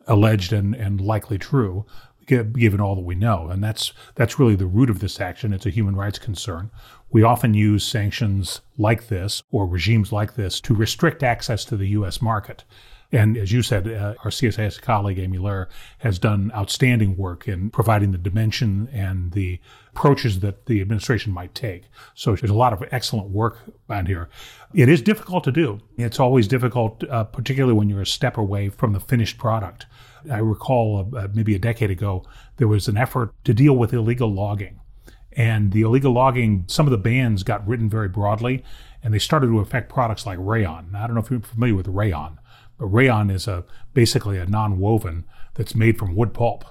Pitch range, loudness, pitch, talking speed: 100-120 Hz, -21 LUFS, 110 Hz, 195 wpm